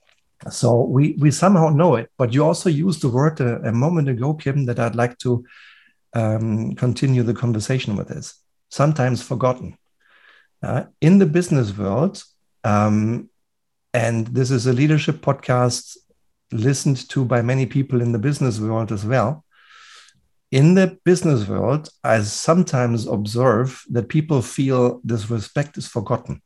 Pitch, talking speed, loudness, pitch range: 125 Hz, 150 wpm, -19 LUFS, 115-145 Hz